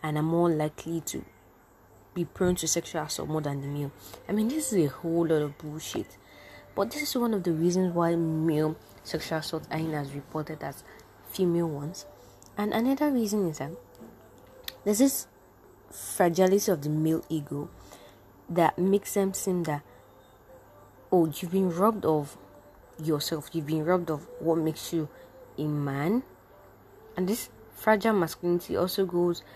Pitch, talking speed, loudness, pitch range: 160 Hz, 160 wpm, -28 LUFS, 145-185 Hz